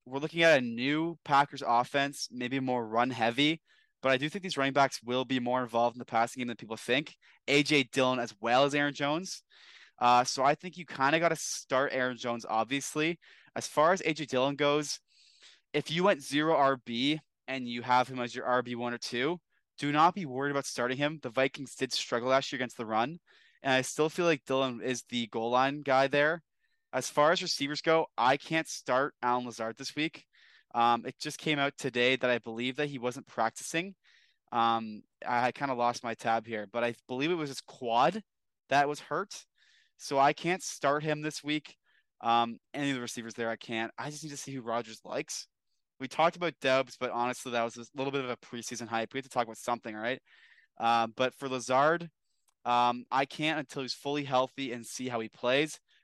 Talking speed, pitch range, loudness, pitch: 215 wpm, 120-150 Hz, -31 LUFS, 130 Hz